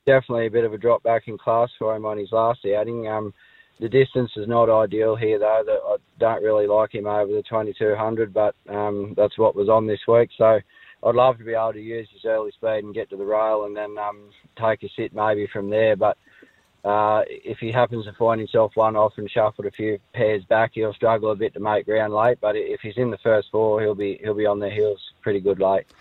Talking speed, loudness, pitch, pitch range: 245 wpm, -22 LUFS, 110 Hz, 105-115 Hz